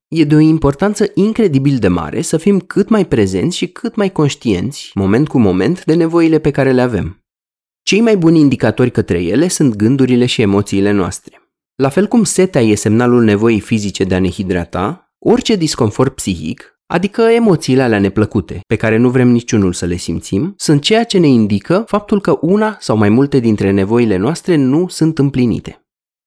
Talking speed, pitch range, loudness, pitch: 185 wpm, 105-170 Hz, -13 LUFS, 130 Hz